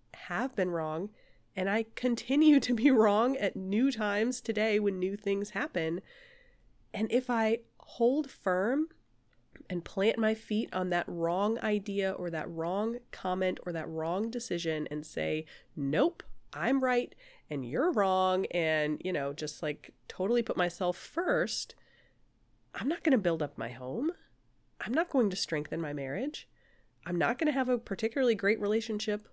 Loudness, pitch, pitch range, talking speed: -31 LUFS, 205 Hz, 175-240 Hz, 160 wpm